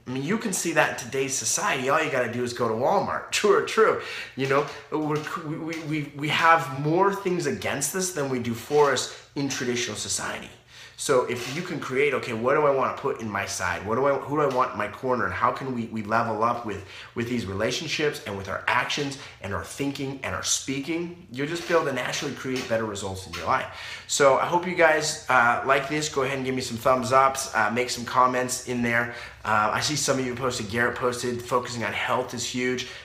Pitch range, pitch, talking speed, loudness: 120-150 Hz, 130 Hz, 240 wpm, -25 LUFS